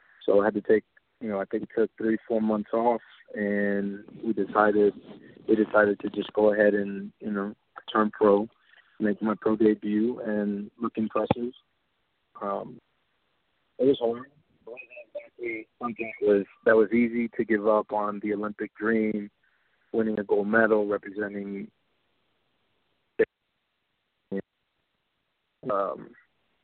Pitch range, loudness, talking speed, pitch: 105-115 Hz, -27 LUFS, 135 wpm, 105 Hz